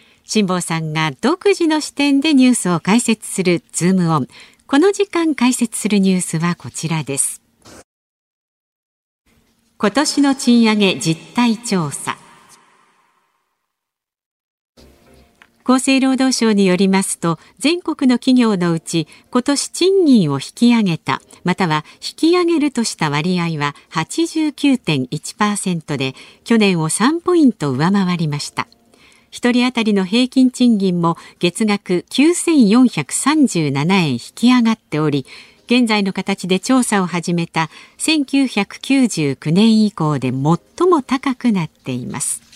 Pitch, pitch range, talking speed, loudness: 210 Hz, 170-260 Hz, 235 characters per minute, -16 LUFS